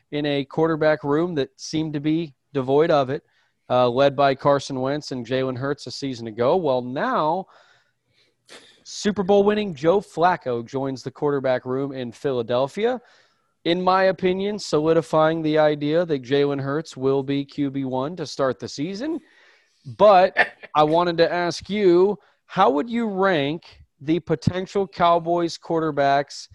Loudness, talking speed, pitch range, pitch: -22 LUFS, 145 wpm, 135-175 Hz, 150 Hz